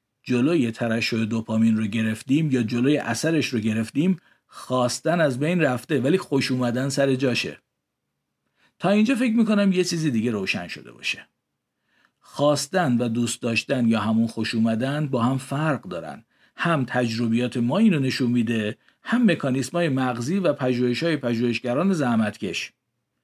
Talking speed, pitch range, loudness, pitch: 140 wpm, 115-155 Hz, -23 LUFS, 130 Hz